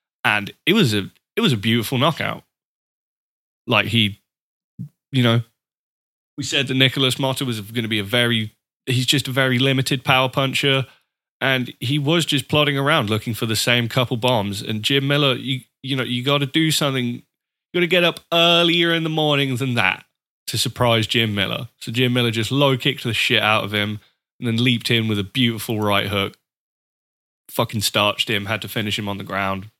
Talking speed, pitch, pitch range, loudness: 195 wpm, 125 Hz, 110-140 Hz, -19 LUFS